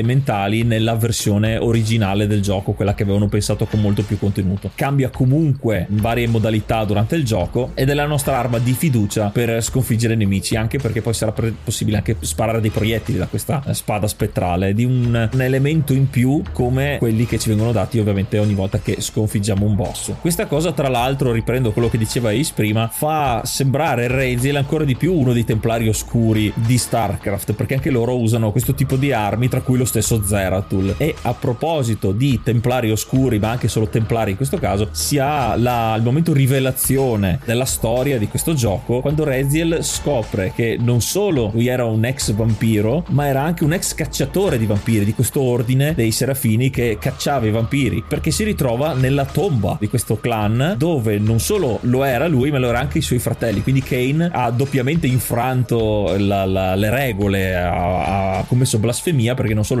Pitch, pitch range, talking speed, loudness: 115 Hz, 110-135 Hz, 190 wpm, -18 LUFS